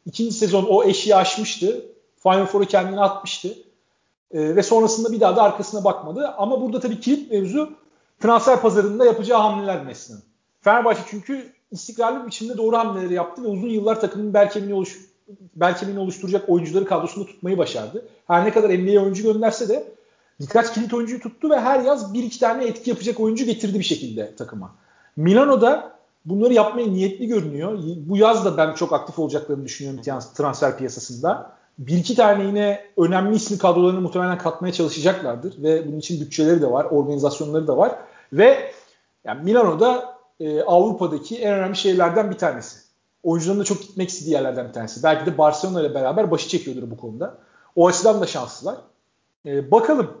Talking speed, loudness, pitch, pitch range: 165 wpm, -20 LUFS, 200 Hz, 170-225 Hz